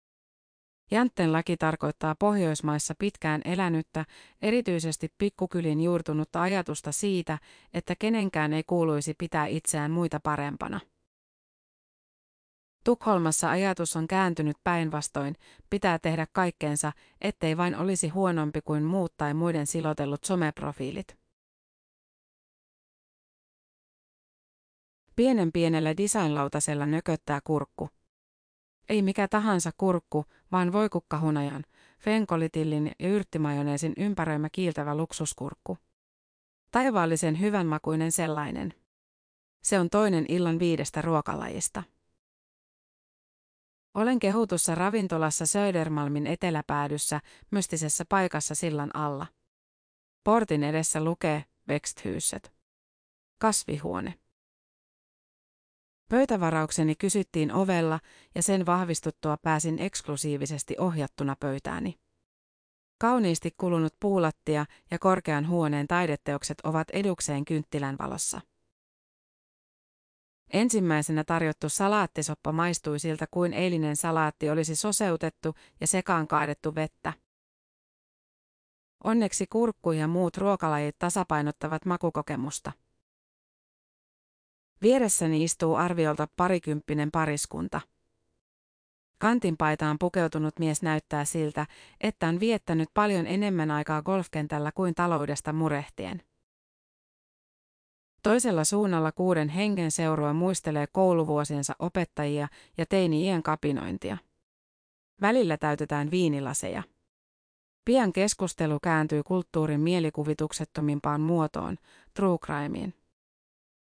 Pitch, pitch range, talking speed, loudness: 160 Hz, 150-185 Hz, 85 wpm, -28 LUFS